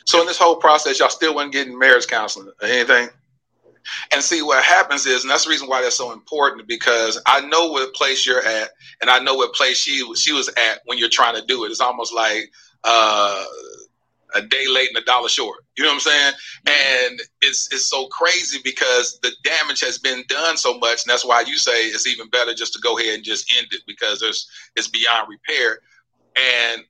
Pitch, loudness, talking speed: 160 Hz, -17 LUFS, 220 wpm